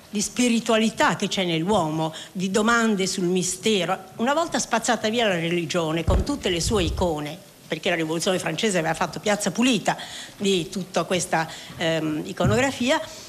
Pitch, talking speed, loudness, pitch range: 190 Hz, 150 wpm, -23 LUFS, 165-220 Hz